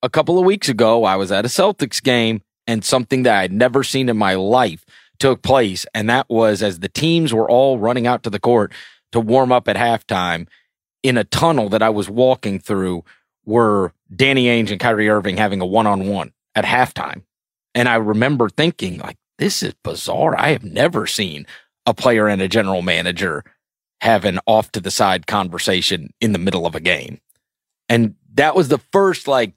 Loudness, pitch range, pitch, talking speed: -17 LUFS, 105-130 Hz, 115 Hz, 195 wpm